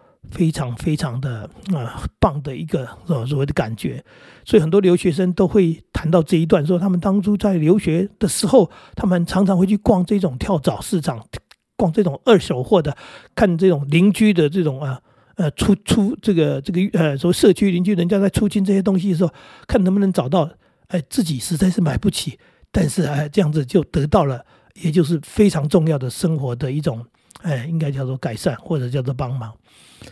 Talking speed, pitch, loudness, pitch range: 290 characters per minute, 175 Hz, -19 LUFS, 145-195 Hz